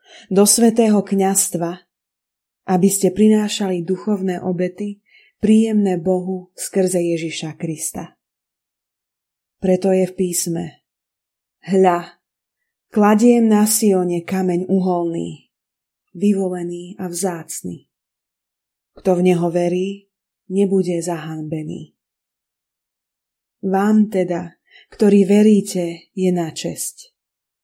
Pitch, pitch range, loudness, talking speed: 185 Hz, 175-200 Hz, -18 LUFS, 85 wpm